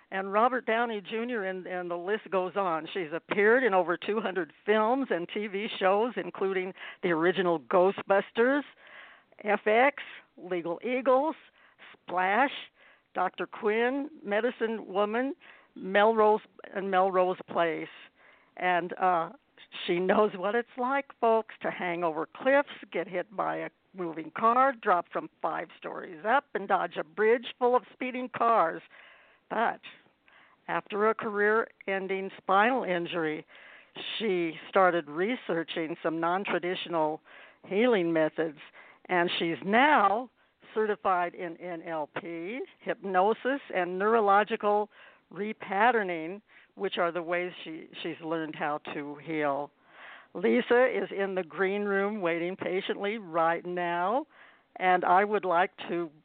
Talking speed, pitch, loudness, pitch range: 125 wpm, 195 Hz, -29 LUFS, 175-220 Hz